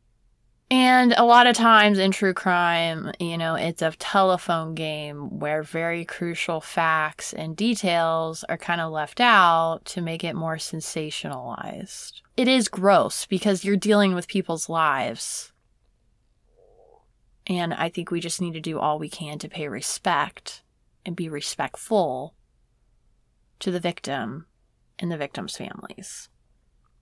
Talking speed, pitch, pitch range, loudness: 140 wpm, 170 Hz, 160-195 Hz, -23 LUFS